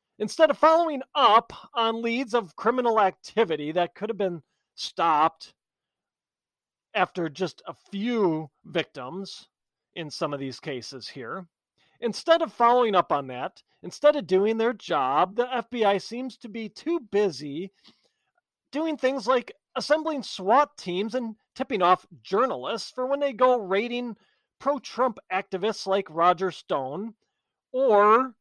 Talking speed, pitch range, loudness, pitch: 135 wpm, 185-255 Hz, -25 LUFS, 220 Hz